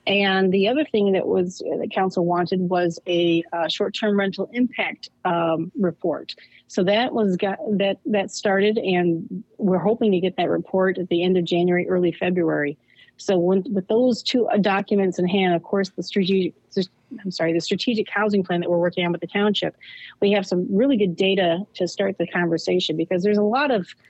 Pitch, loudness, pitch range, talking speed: 190 Hz, -22 LUFS, 175-205 Hz, 195 wpm